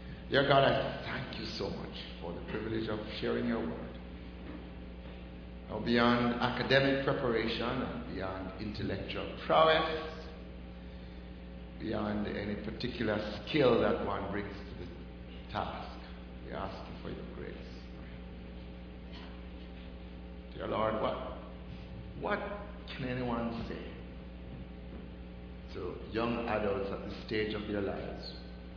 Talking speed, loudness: 115 wpm, -34 LUFS